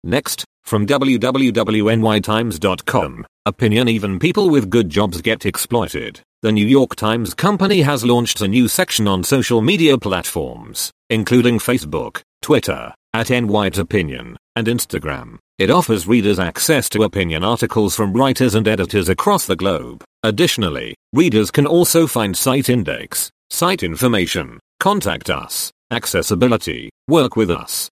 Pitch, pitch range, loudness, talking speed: 115 Hz, 105-125 Hz, -17 LUFS, 135 wpm